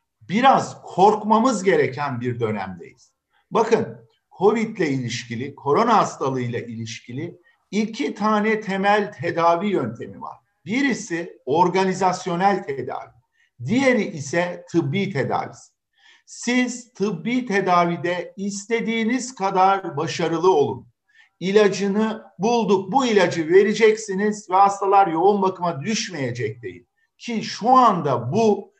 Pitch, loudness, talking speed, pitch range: 200 Hz, -21 LUFS, 95 wpm, 170-225 Hz